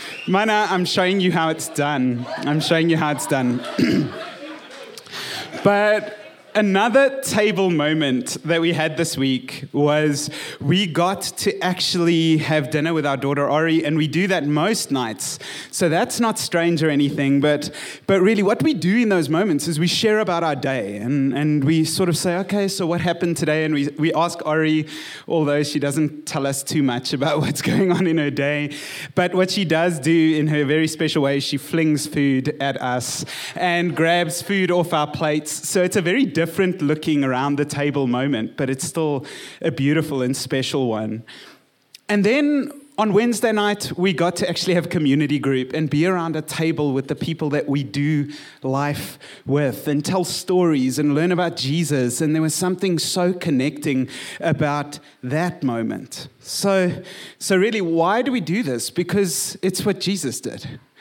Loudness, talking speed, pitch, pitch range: -20 LUFS, 180 wpm, 160 Hz, 145-180 Hz